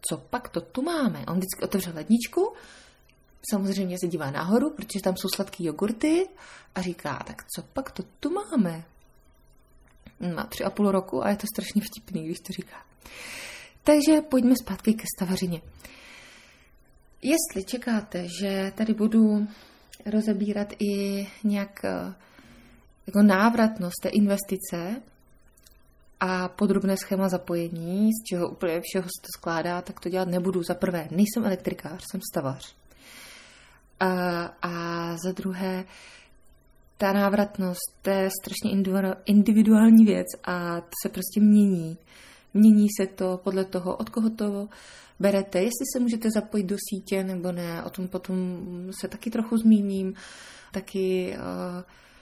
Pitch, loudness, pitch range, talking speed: 195 Hz, -26 LUFS, 180-215 Hz, 135 wpm